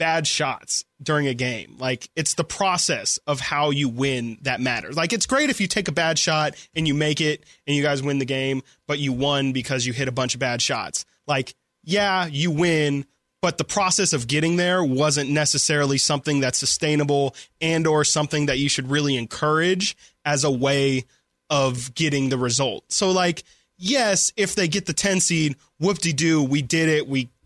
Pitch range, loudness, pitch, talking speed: 135-165 Hz, -22 LUFS, 150 Hz, 200 wpm